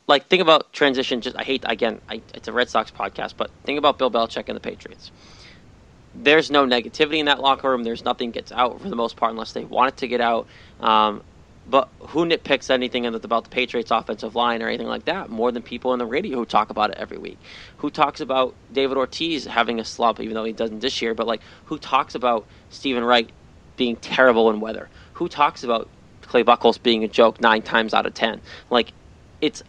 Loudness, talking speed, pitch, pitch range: -21 LUFS, 220 wpm, 125 Hz, 115-135 Hz